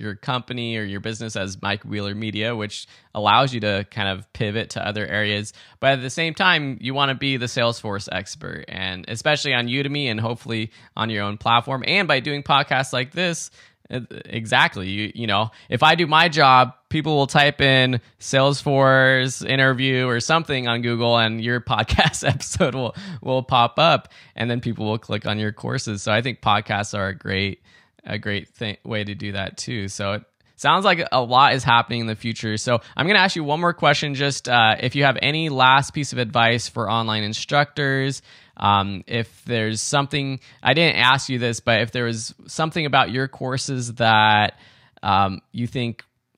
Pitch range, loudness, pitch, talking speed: 110-135 Hz, -20 LUFS, 120 Hz, 195 wpm